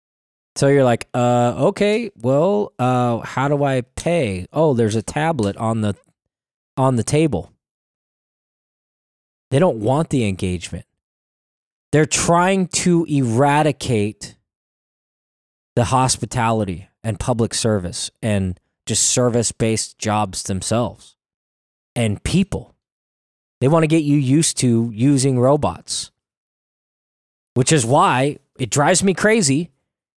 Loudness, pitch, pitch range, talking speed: -18 LUFS, 120 Hz, 100-145 Hz, 115 wpm